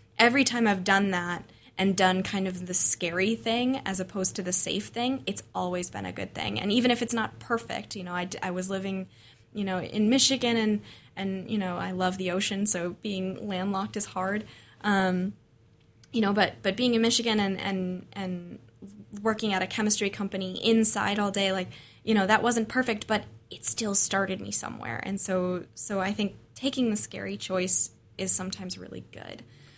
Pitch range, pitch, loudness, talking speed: 180-215 Hz, 195 Hz, -26 LUFS, 195 wpm